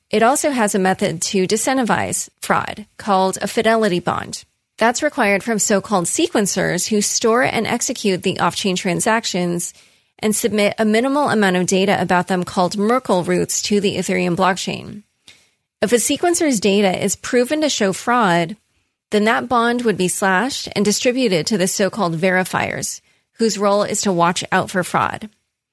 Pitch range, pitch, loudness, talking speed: 185-230 Hz, 205 Hz, -17 LUFS, 160 wpm